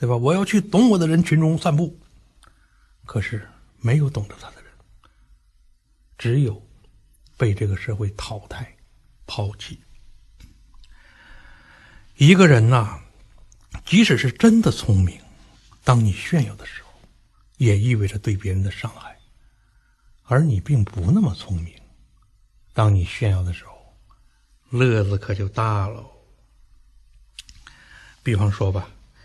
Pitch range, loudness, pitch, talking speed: 100-130 Hz, -20 LUFS, 110 Hz, 175 characters per minute